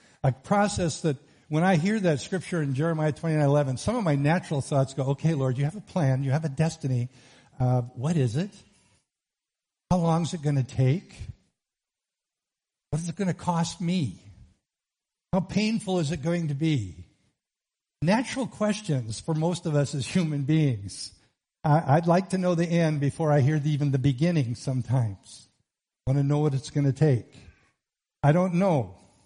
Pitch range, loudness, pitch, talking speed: 135-170 Hz, -26 LUFS, 150 Hz, 185 wpm